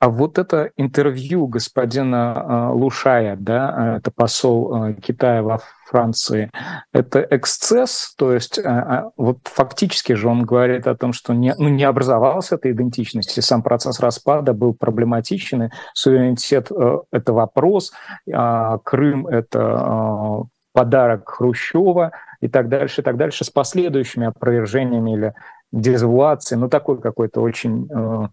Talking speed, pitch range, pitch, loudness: 125 wpm, 115-135 Hz, 125 Hz, -18 LUFS